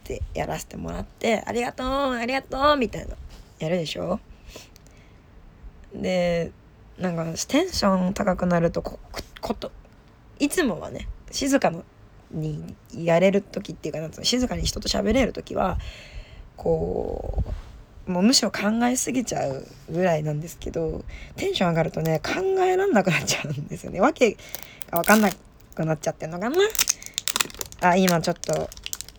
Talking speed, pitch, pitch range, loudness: 315 characters per minute, 185 Hz, 165-255 Hz, -24 LUFS